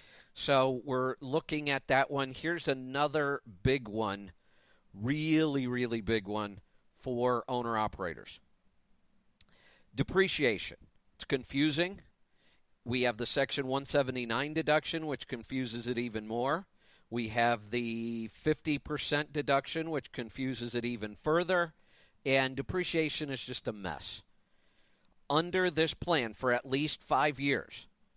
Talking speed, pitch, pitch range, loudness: 115 wpm, 135 Hz, 120-150 Hz, -33 LUFS